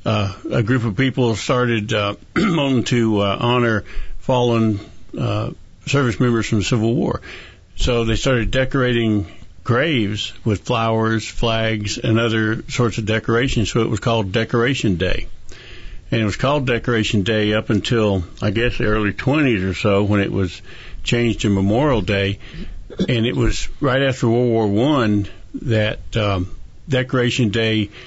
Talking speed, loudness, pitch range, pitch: 150 wpm, -19 LUFS, 105-120 Hz, 110 Hz